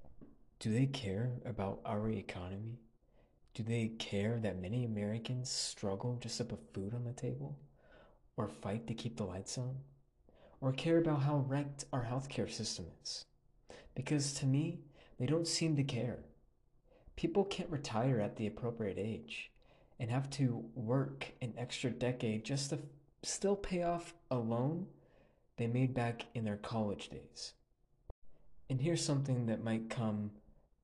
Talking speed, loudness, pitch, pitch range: 150 wpm, -39 LUFS, 120 Hz, 110-140 Hz